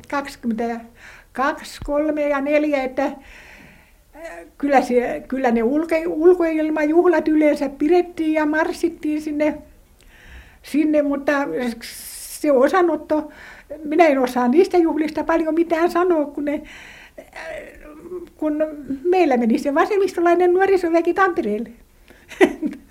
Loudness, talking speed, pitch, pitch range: -19 LUFS, 95 wpm, 305 Hz, 280-335 Hz